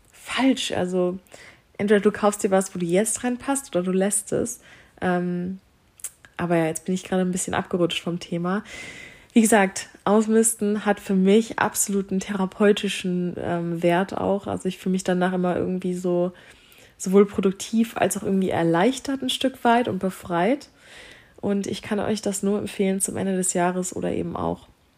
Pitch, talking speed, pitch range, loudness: 190 Hz, 170 wpm, 180-210 Hz, -23 LUFS